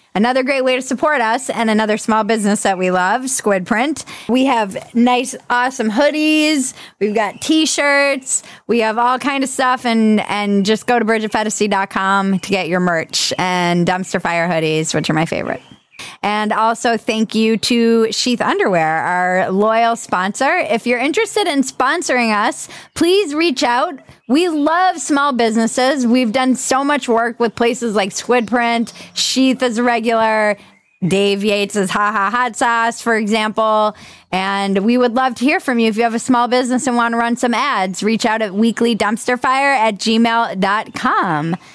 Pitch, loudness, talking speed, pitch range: 230 Hz, -16 LUFS, 170 wpm, 205-255 Hz